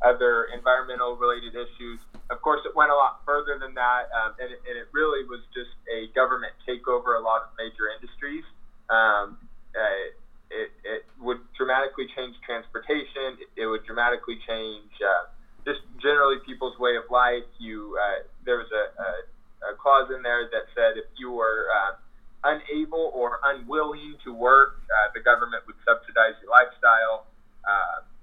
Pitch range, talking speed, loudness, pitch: 115-145 Hz, 165 wpm, -24 LUFS, 125 Hz